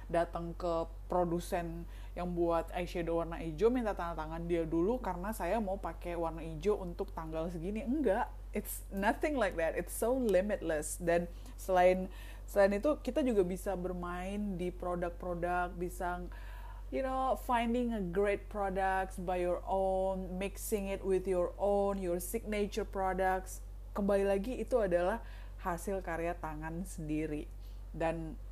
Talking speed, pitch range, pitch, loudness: 140 wpm, 170-200 Hz, 180 Hz, -35 LUFS